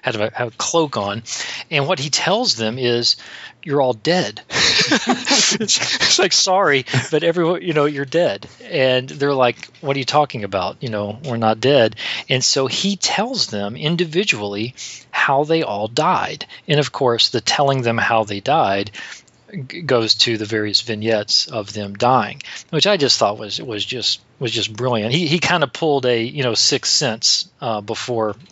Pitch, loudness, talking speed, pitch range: 130 Hz, -17 LUFS, 185 wpm, 110-155 Hz